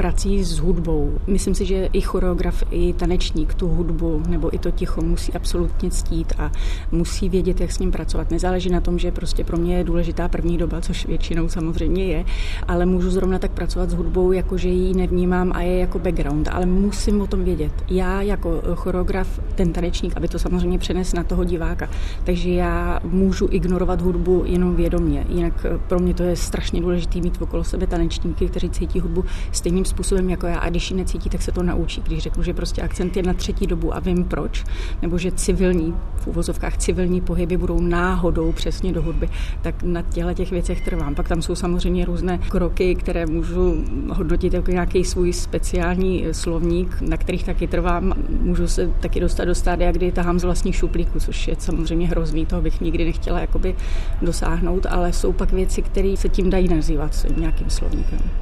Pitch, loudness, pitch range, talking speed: 175 Hz, -22 LUFS, 165-180 Hz, 190 wpm